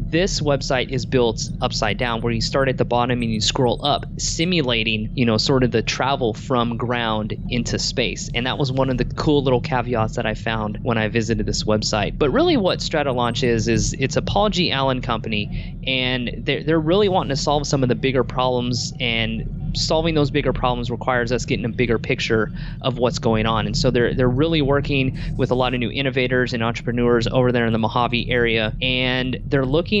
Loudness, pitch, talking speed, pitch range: -20 LUFS, 125 Hz, 210 wpm, 115-140 Hz